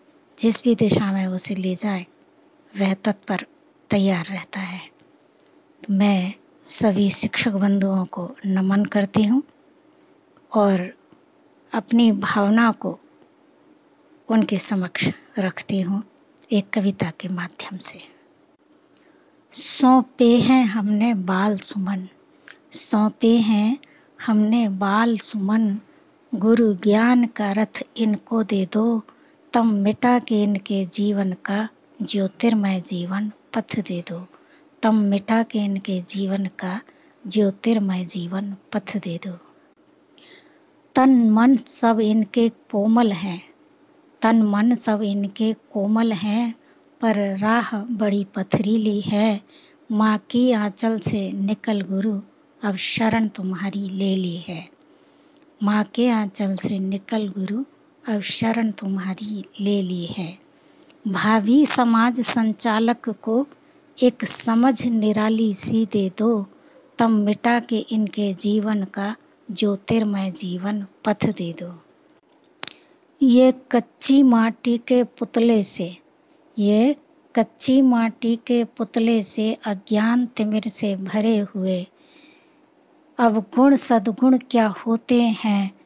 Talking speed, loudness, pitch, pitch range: 110 wpm, -21 LUFS, 225 Hz, 200-265 Hz